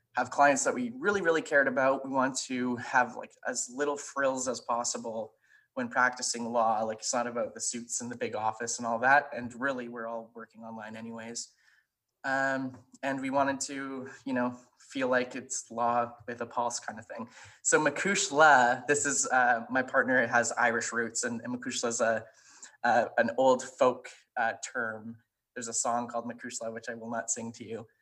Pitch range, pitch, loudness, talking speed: 115-135 Hz, 125 Hz, -29 LUFS, 195 wpm